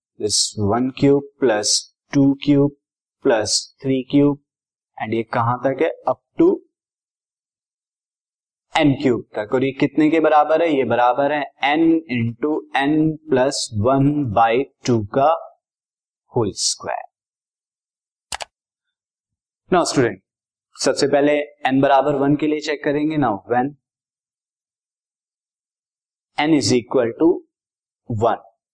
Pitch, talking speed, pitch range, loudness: 140 Hz, 115 wpm, 125-150 Hz, -19 LUFS